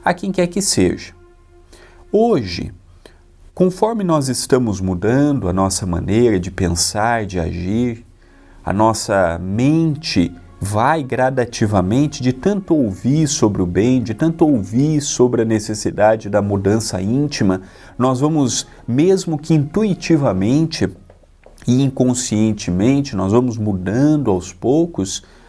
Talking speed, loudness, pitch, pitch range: 115 wpm, -17 LUFS, 110 Hz, 95-140 Hz